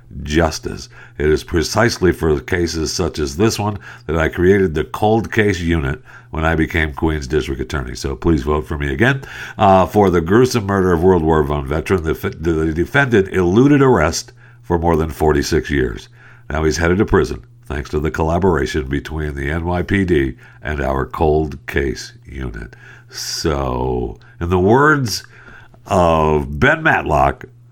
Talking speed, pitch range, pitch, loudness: 160 wpm, 75-100 Hz, 85 Hz, -17 LUFS